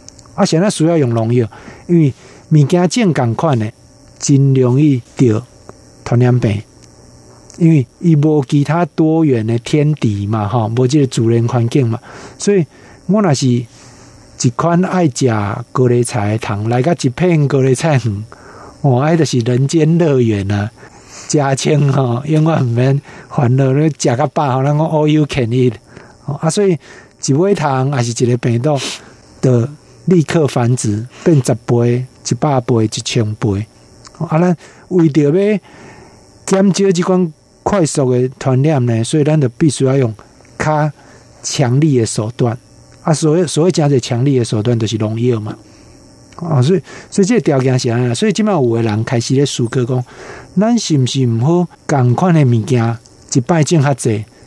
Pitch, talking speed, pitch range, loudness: 135 Hz, 235 characters per minute, 120-155 Hz, -14 LUFS